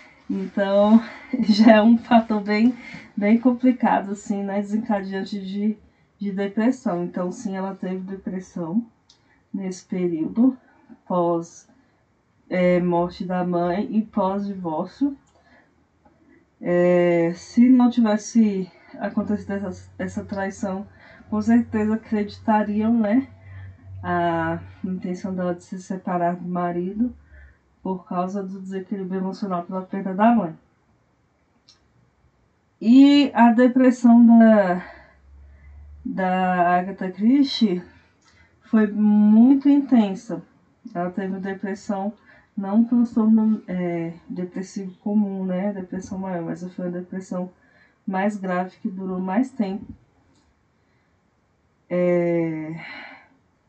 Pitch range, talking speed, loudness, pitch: 180-220 Hz, 105 wpm, -21 LUFS, 195 Hz